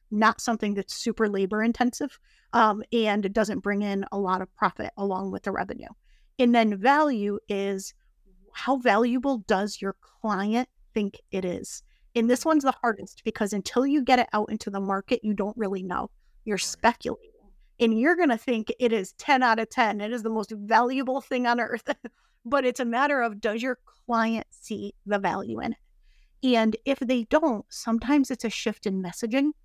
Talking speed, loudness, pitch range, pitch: 190 wpm, -26 LUFS, 205-250 Hz, 225 Hz